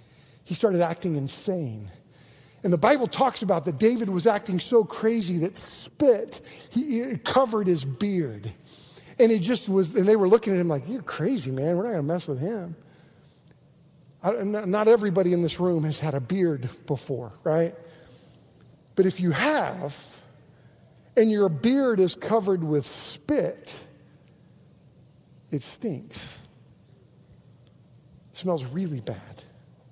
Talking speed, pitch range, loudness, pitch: 140 wpm, 150-205 Hz, -25 LUFS, 175 Hz